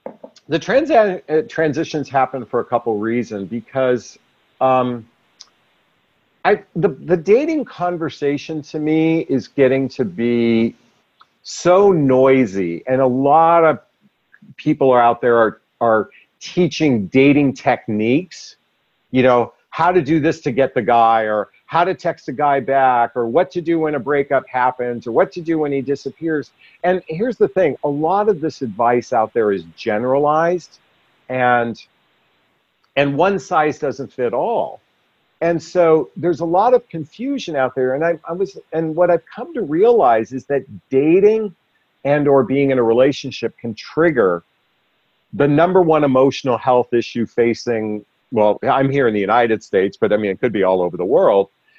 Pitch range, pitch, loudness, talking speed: 120-165 Hz, 140 Hz, -17 LUFS, 165 wpm